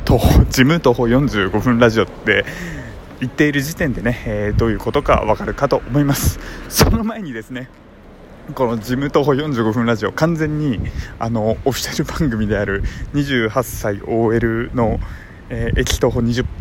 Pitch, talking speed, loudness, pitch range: 120 Hz, 285 characters per minute, -17 LUFS, 110-135 Hz